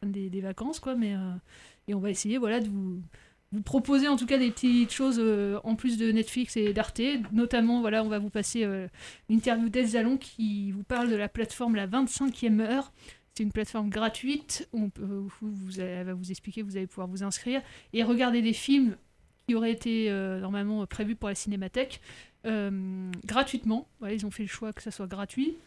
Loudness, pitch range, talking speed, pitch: -30 LUFS, 200-240 Hz, 205 wpm, 220 Hz